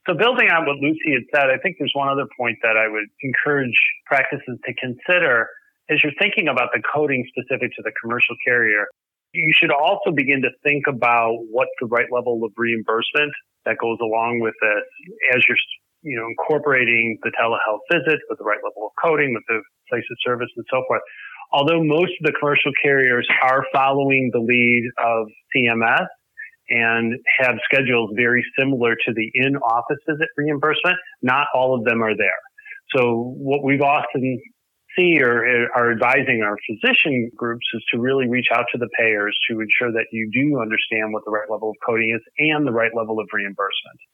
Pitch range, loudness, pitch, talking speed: 115-145 Hz, -19 LUFS, 125 Hz, 185 wpm